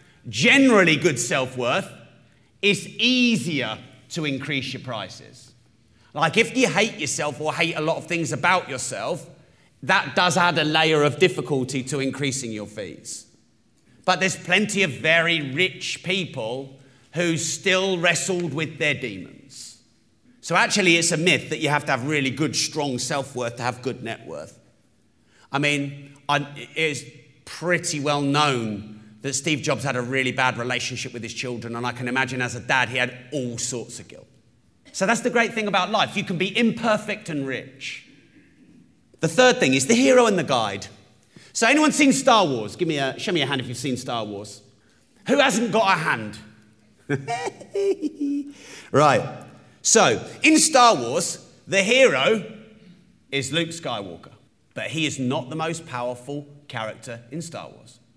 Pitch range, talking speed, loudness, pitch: 125-180 Hz, 165 wpm, -21 LUFS, 145 Hz